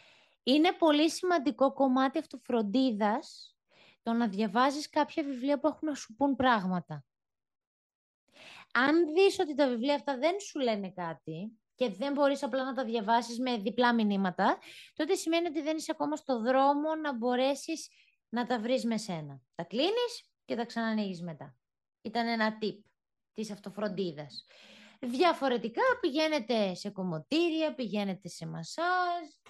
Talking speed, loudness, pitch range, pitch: 140 wpm, -31 LUFS, 215-305 Hz, 255 Hz